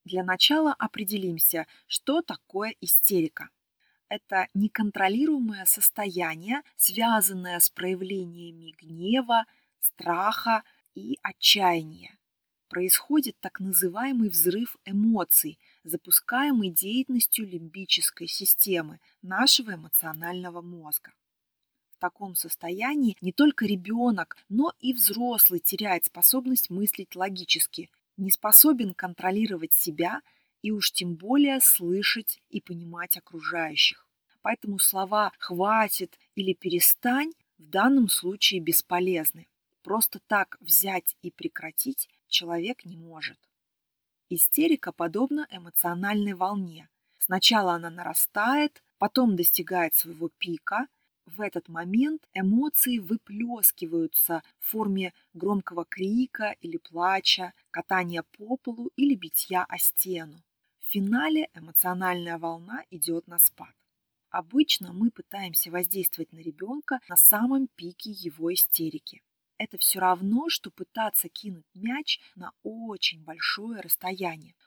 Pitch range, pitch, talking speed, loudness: 175-230 Hz, 190 Hz, 105 wpm, -24 LUFS